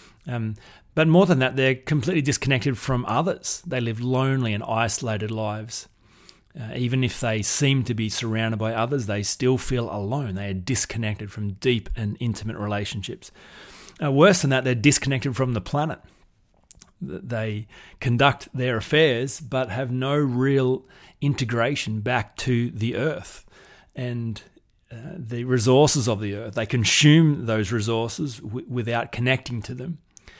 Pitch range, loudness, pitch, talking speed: 110-135 Hz, -23 LUFS, 125 Hz, 150 wpm